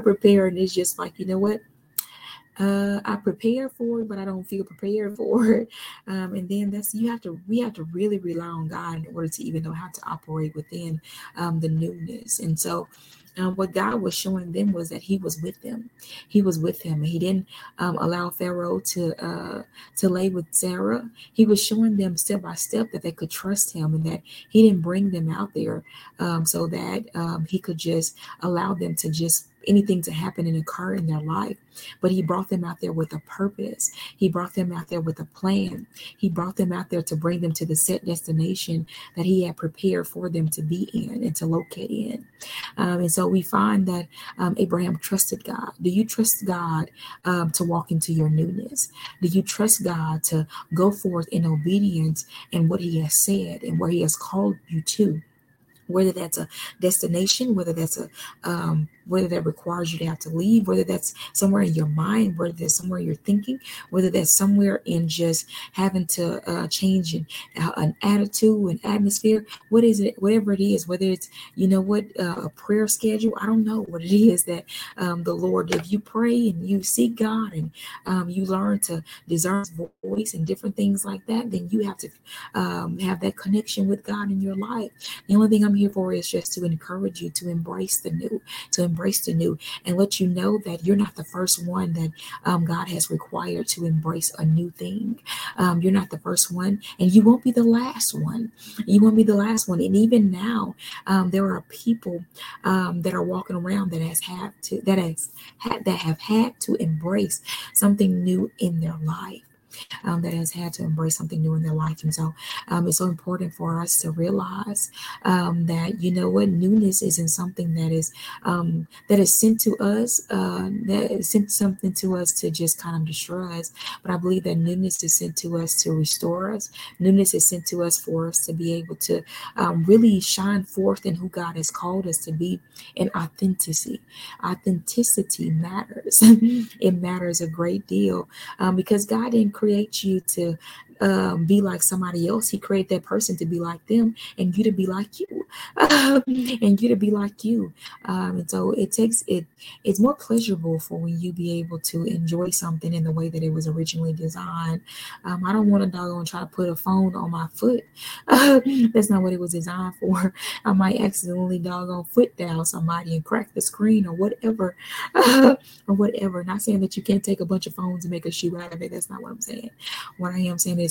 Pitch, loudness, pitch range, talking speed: 185 Hz, -23 LUFS, 170-205 Hz, 210 wpm